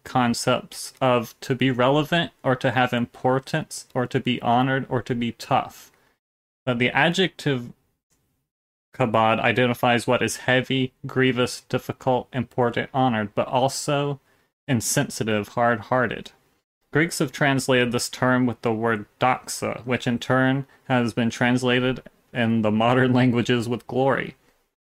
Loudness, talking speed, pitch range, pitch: -23 LUFS, 135 wpm, 120-130 Hz, 125 Hz